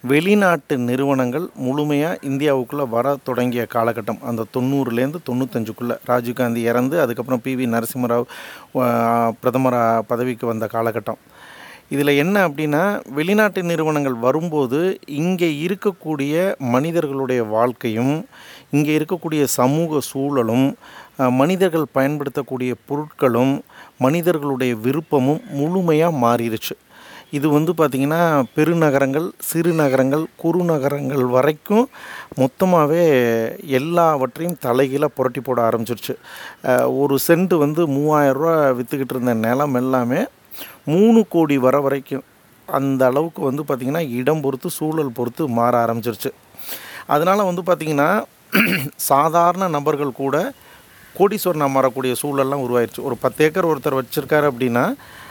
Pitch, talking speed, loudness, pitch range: 140 Hz, 100 wpm, -19 LUFS, 125-155 Hz